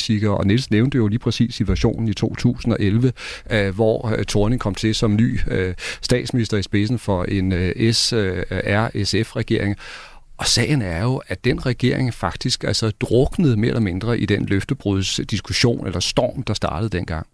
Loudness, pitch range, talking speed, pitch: -20 LUFS, 100-120 Hz, 150 wpm, 110 Hz